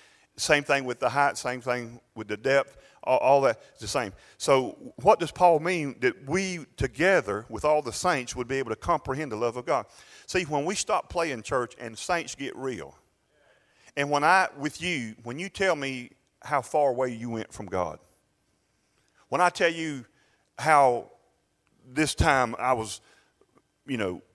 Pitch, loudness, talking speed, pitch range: 135 Hz, -27 LUFS, 180 wpm, 120-155 Hz